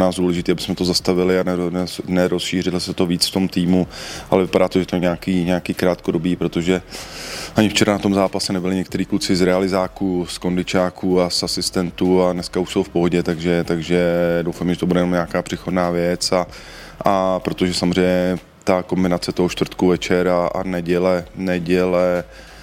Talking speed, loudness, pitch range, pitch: 175 wpm, -19 LUFS, 90-95 Hz, 90 Hz